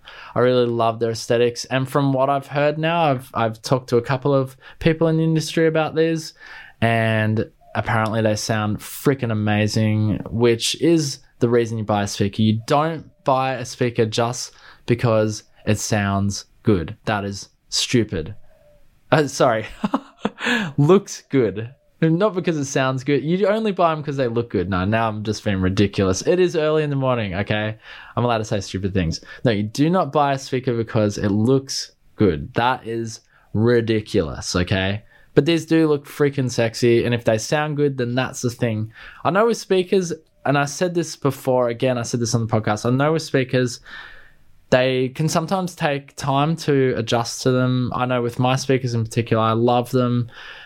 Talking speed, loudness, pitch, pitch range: 185 wpm, -20 LUFS, 125 Hz, 110-145 Hz